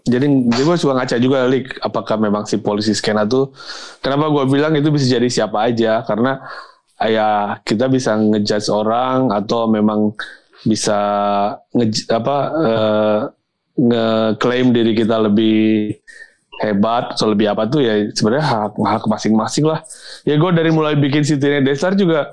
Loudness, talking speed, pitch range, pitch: -16 LUFS, 155 wpm, 110-135 Hz, 115 Hz